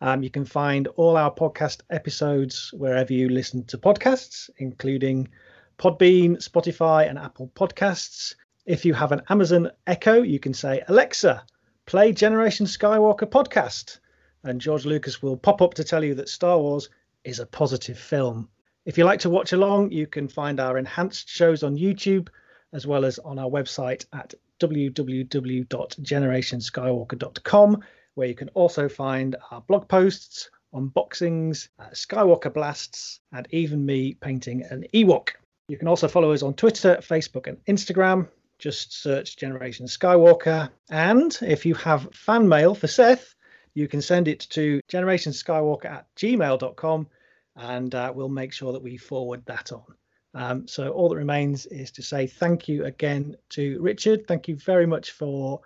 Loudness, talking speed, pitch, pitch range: -22 LUFS, 160 wpm, 150 Hz, 130-175 Hz